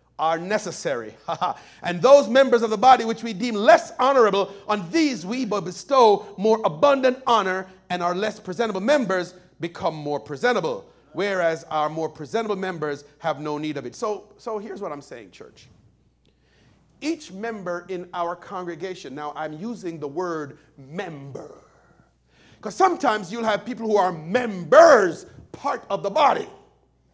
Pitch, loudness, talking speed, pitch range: 195 Hz, -22 LUFS, 155 wpm, 170-235 Hz